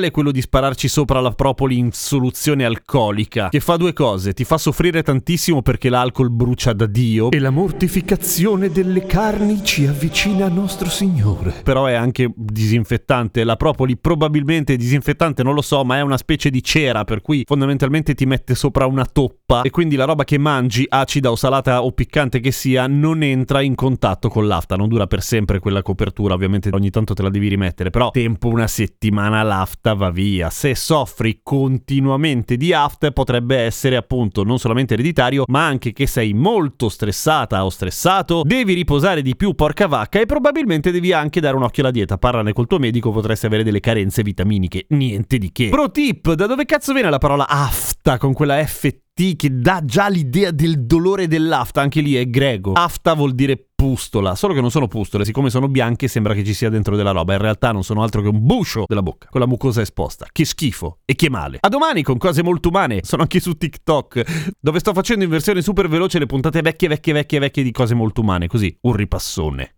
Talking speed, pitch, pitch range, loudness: 200 wpm, 135 Hz, 115-155 Hz, -17 LUFS